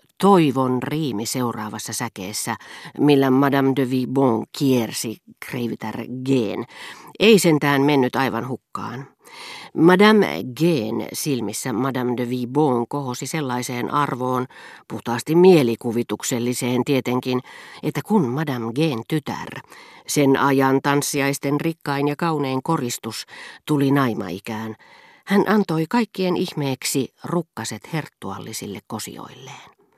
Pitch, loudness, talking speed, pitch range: 135 Hz, -21 LUFS, 100 wpm, 120-150 Hz